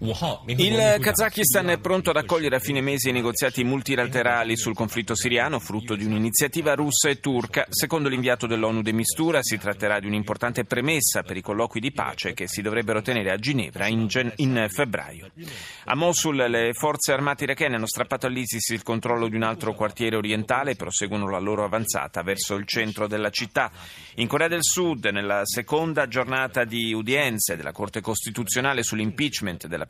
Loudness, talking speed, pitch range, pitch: -24 LUFS, 175 wpm, 110-140 Hz, 120 Hz